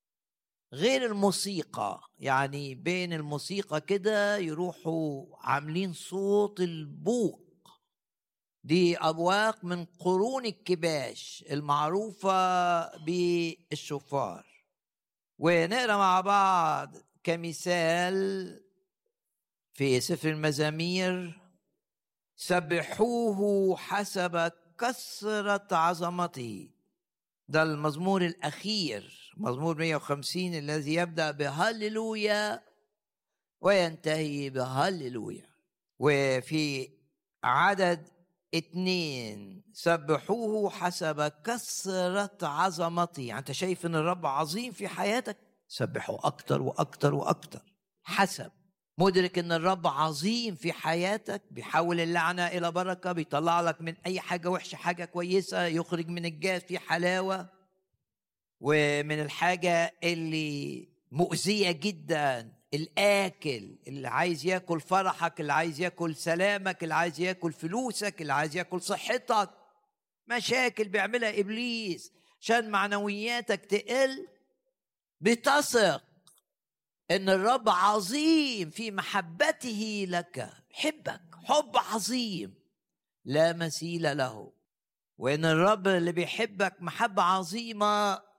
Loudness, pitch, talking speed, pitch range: -29 LUFS, 180 Hz, 85 wpm, 160-200 Hz